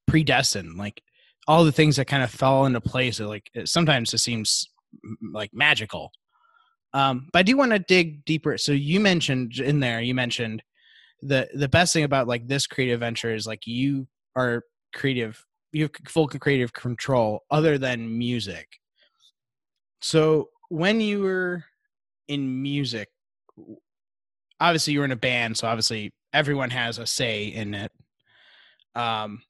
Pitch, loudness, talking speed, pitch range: 135 Hz, -23 LUFS, 155 wpm, 115-155 Hz